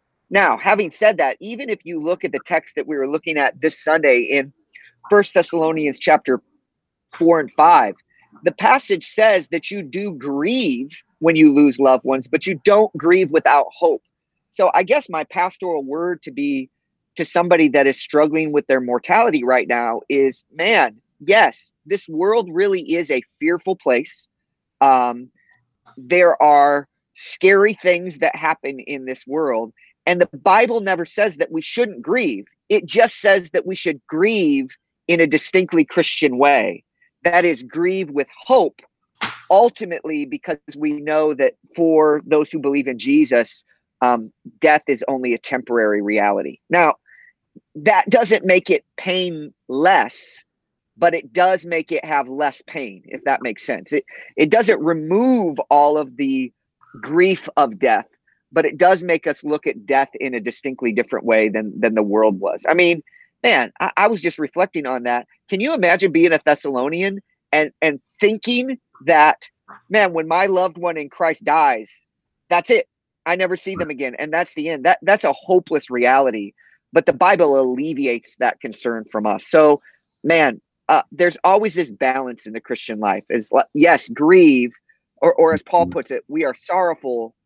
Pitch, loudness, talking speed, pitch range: 165 Hz, -17 LUFS, 170 wpm, 140-205 Hz